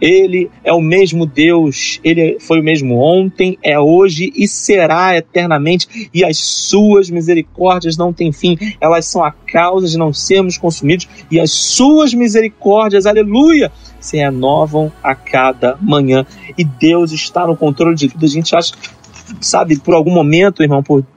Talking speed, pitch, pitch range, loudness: 160 wpm, 170 Hz, 155-190 Hz, -11 LUFS